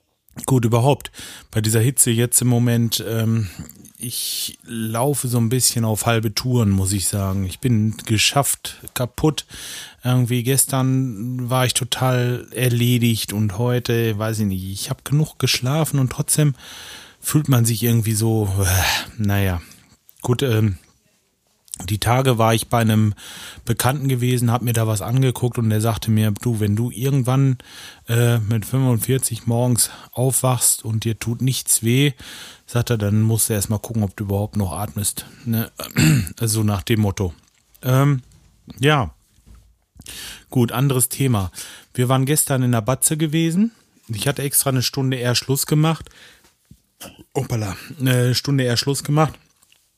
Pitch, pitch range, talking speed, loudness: 120 Hz, 110-130 Hz, 150 wpm, -19 LUFS